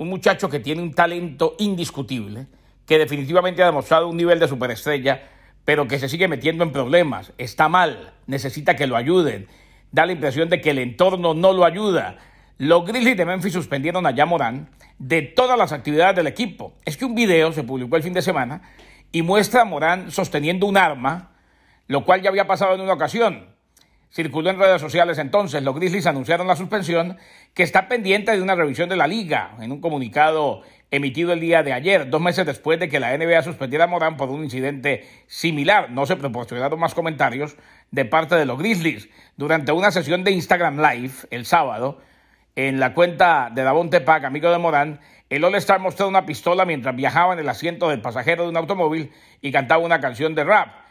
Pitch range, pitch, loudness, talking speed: 145-185 Hz, 165 Hz, -19 LUFS, 195 wpm